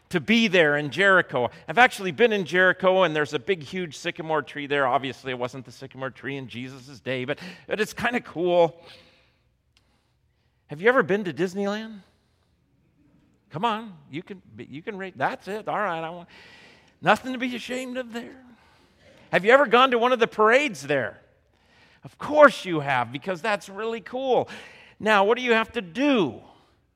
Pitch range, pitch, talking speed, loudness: 145-230 Hz, 185 Hz, 185 wpm, -23 LUFS